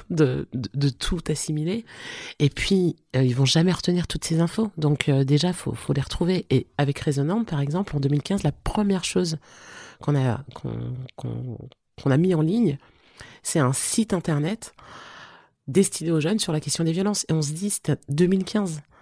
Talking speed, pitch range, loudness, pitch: 190 wpm, 140-185 Hz, -24 LUFS, 155 Hz